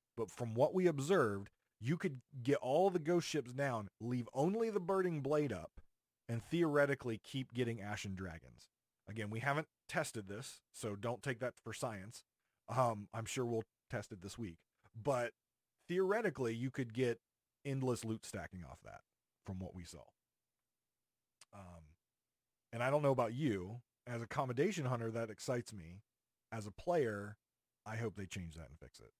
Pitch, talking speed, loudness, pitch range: 120 Hz, 170 wpm, -40 LUFS, 105-135 Hz